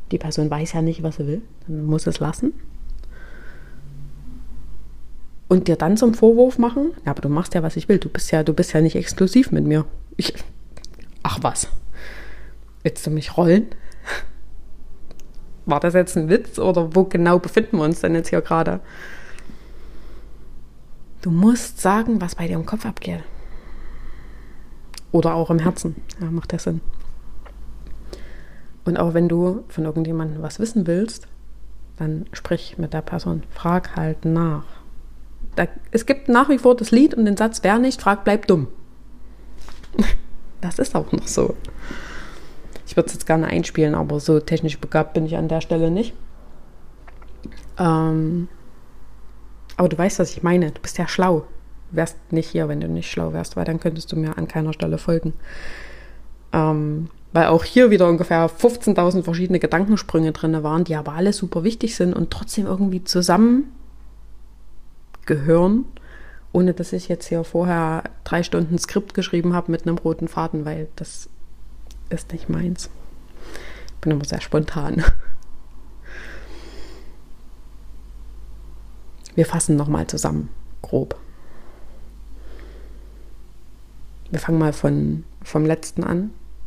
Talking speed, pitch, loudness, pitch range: 150 wpm, 165 Hz, -20 LUFS, 155-180 Hz